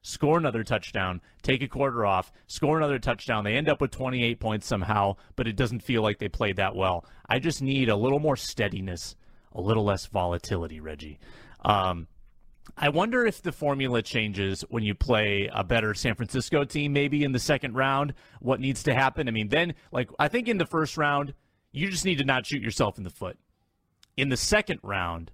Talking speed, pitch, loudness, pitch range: 205 wpm, 120 Hz, -27 LUFS, 100-140 Hz